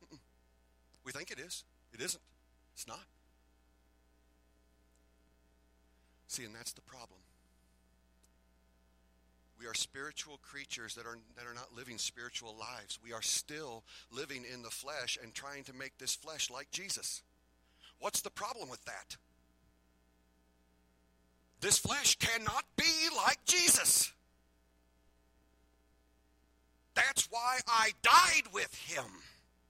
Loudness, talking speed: -32 LUFS, 115 wpm